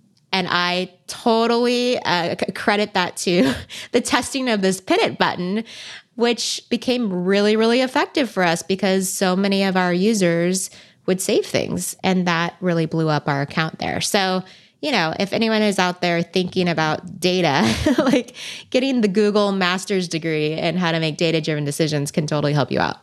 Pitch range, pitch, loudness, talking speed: 170-220 Hz, 185 Hz, -20 LUFS, 175 wpm